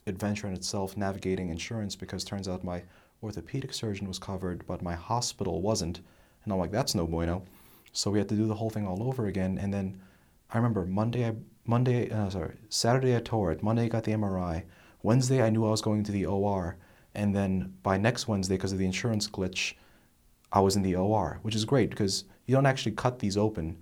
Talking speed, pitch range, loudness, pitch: 215 wpm, 95-110 Hz, -30 LUFS, 100 Hz